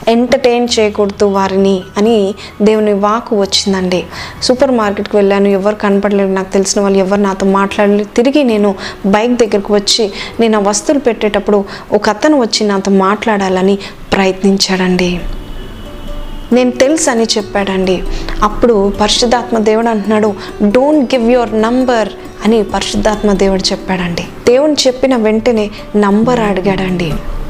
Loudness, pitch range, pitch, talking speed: -11 LUFS, 195-230 Hz, 210 Hz, 120 wpm